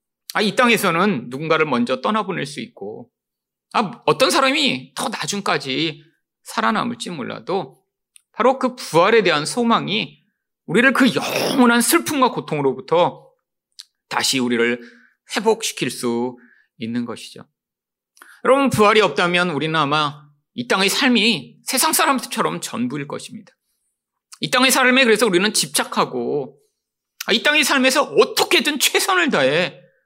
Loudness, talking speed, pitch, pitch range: -18 LUFS, 285 characters per minute, 225 Hz, 155-260 Hz